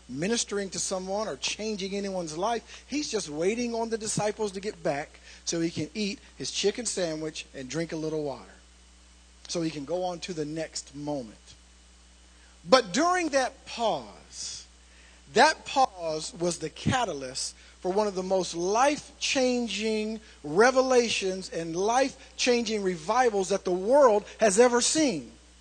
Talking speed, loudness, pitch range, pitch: 150 wpm, -27 LUFS, 150-225 Hz, 185 Hz